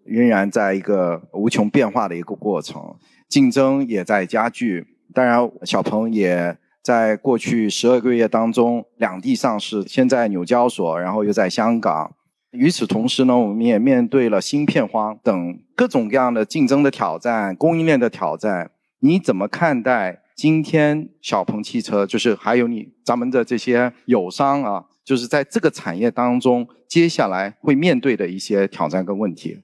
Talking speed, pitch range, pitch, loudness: 255 characters per minute, 105-135 Hz, 120 Hz, -19 LUFS